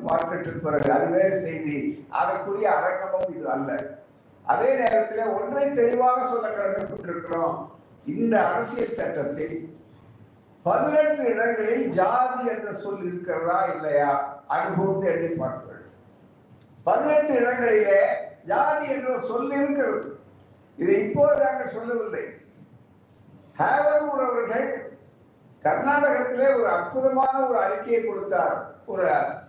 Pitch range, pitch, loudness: 180-275 Hz, 230 Hz, -24 LUFS